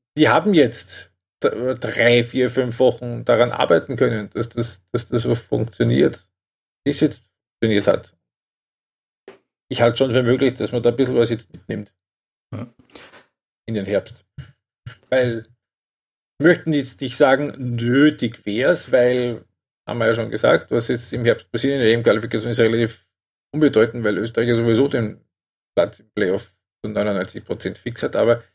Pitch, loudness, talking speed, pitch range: 120 Hz, -19 LUFS, 160 wpm, 115-130 Hz